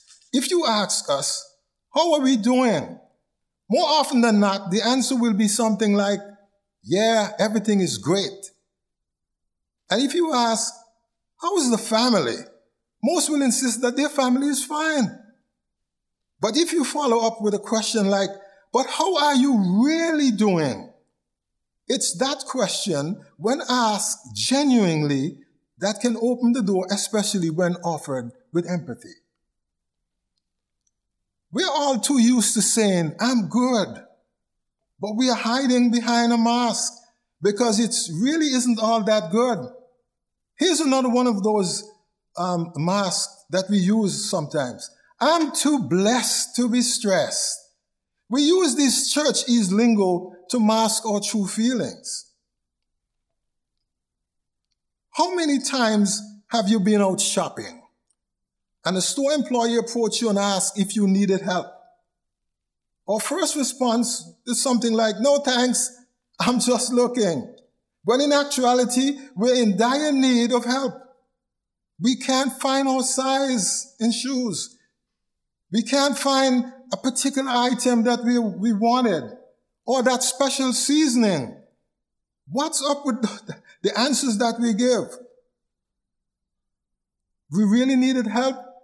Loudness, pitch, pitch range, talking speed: -21 LUFS, 235 Hz, 200-260 Hz, 130 wpm